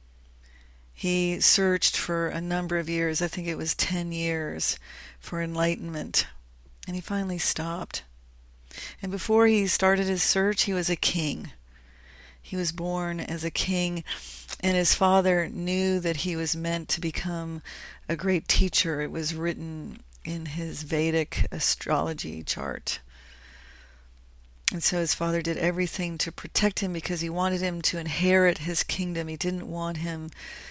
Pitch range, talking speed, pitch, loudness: 155-180 Hz, 150 wpm, 170 Hz, -26 LUFS